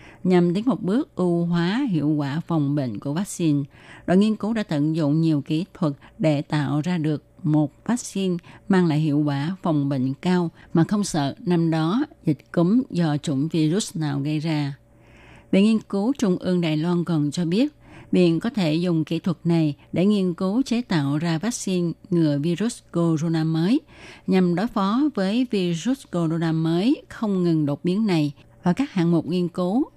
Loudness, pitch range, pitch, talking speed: -23 LUFS, 155-190 Hz, 170 Hz, 185 wpm